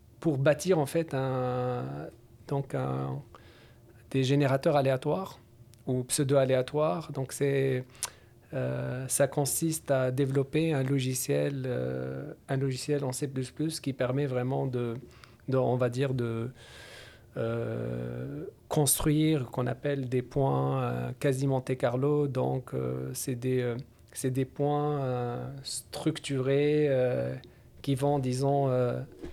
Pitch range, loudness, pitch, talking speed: 120-140 Hz, -30 LUFS, 130 Hz, 125 wpm